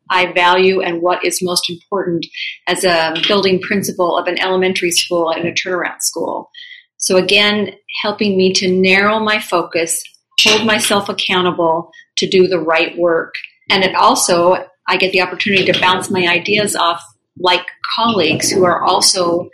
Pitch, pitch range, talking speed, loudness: 185 Hz, 175-205 Hz, 160 wpm, -14 LUFS